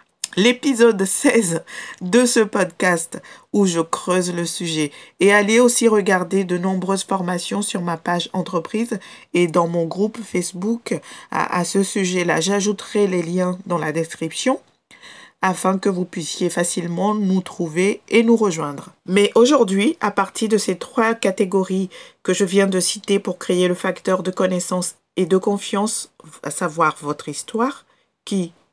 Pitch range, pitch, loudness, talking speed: 175-210 Hz, 190 Hz, -19 LUFS, 150 wpm